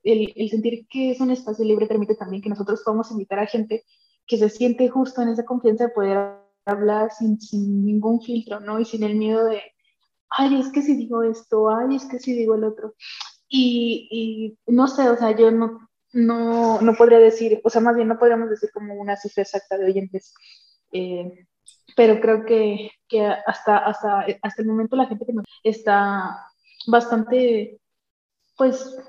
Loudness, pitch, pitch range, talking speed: -20 LUFS, 225 Hz, 210-235 Hz, 190 wpm